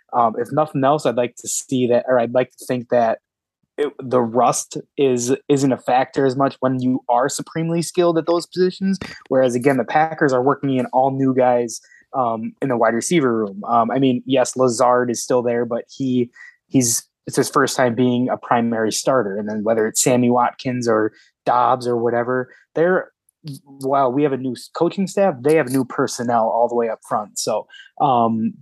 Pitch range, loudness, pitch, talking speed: 120-140 Hz, -19 LUFS, 125 Hz, 200 wpm